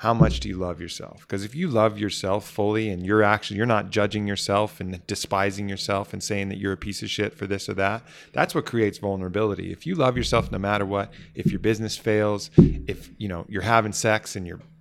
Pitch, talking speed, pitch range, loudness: 105 Hz, 230 wpm, 100-110 Hz, -24 LUFS